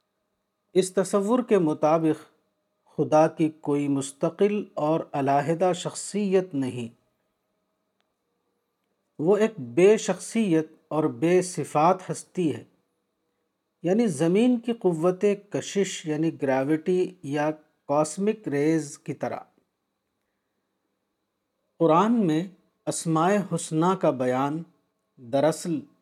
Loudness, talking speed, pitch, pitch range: -25 LUFS, 90 wpm, 160 Hz, 150-190 Hz